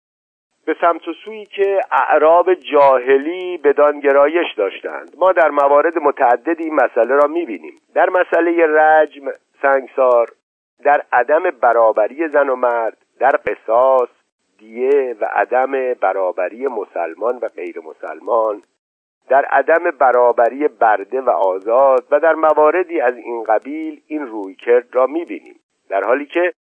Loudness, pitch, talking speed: -15 LUFS, 160 Hz, 125 wpm